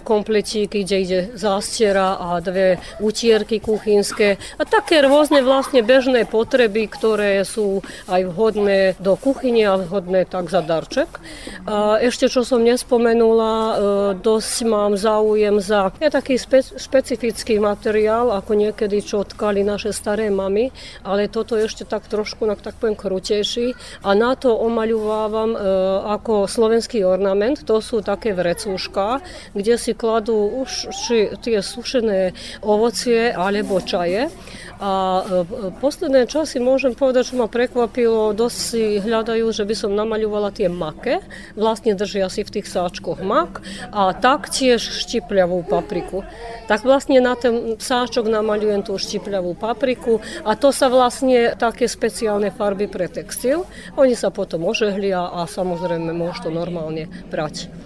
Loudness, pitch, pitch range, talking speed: -19 LUFS, 215 Hz, 195-235 Hz, 140 wpm